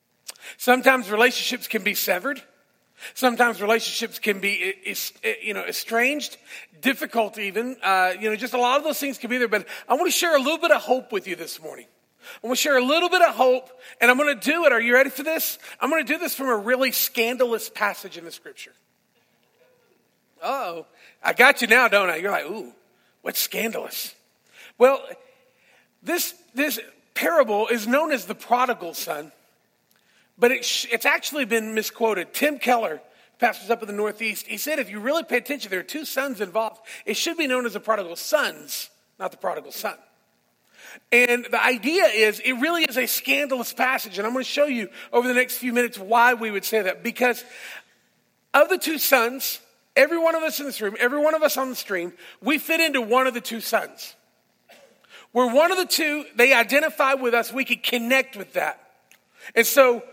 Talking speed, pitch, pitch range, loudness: 200 wpm, 250 Hz, 225-285 Hz, -22 LUFS